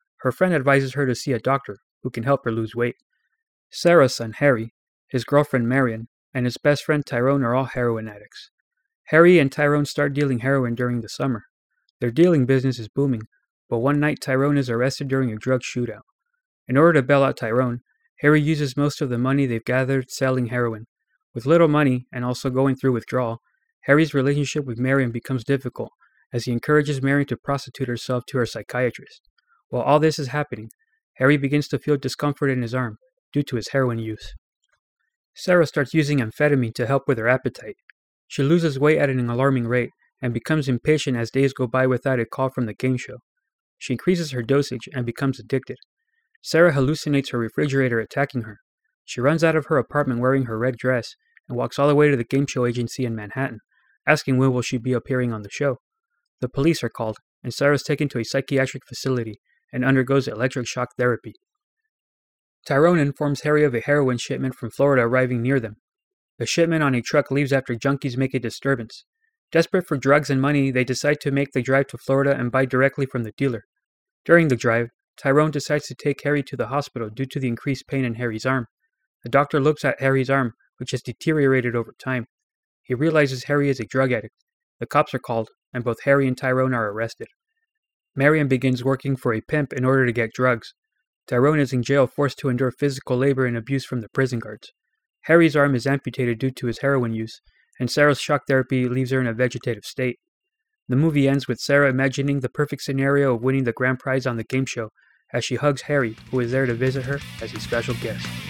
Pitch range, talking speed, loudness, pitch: 125-145 Hz, 205 wpm, -22 LUFS, 135 Hz